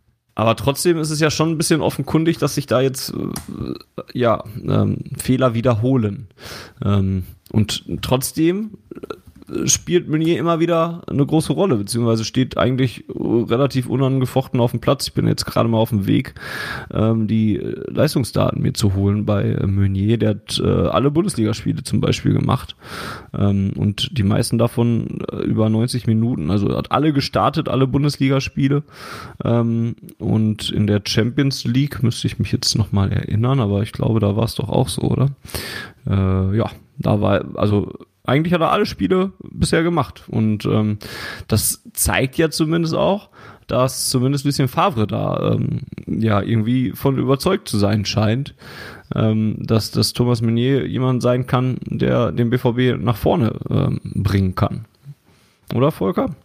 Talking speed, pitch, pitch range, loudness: 150 wpm, 120 Hz, 110-140 Hz, -19 LUFS